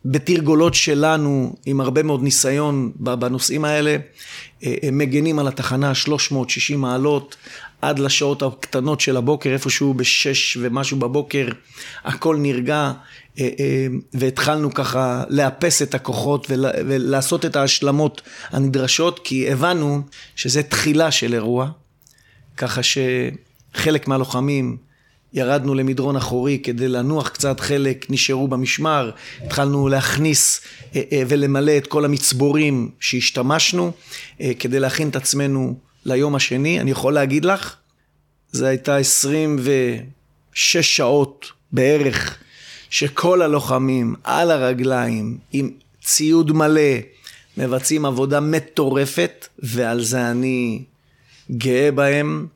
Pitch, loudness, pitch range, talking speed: 135 Hz, -18 LUFS, 130-145 Hz, 100 wpm